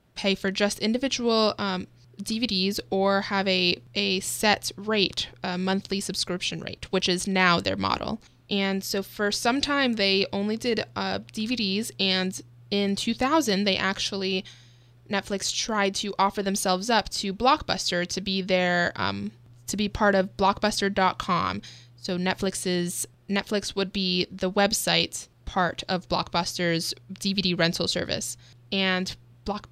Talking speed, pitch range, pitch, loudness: 135 wpm, 180-200 Hz, 195 Hz, -25 LUFS